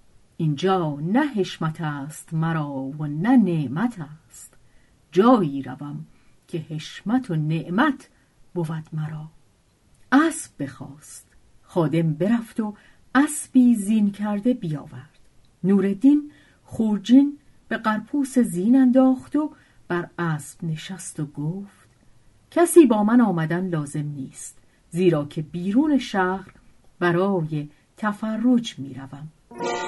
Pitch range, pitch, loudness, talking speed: 150-225 Hz, 170 Hz, -22 LUFS, 105 wpm